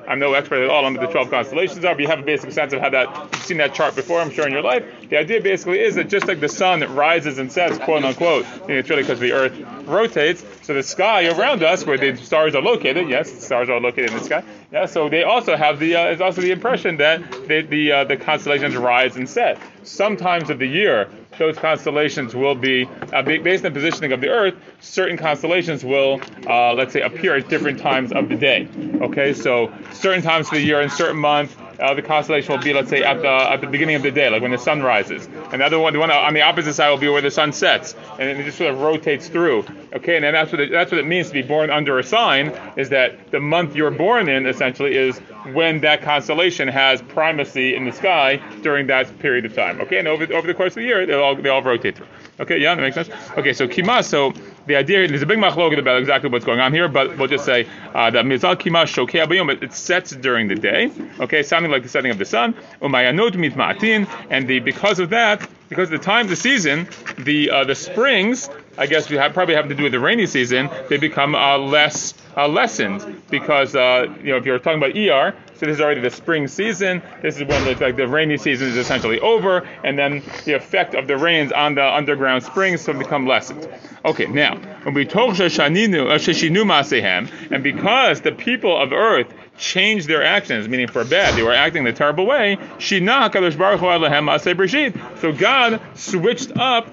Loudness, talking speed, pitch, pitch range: -17 LUFS, 225 wpm, 150 Hz, 140-180 Hz